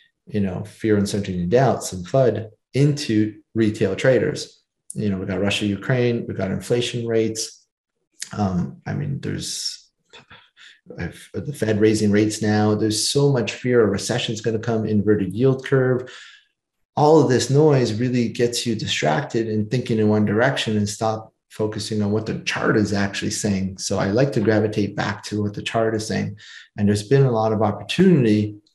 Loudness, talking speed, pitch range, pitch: -21 LUFS, 175 wpm, 105-125 Hz, 110 Hz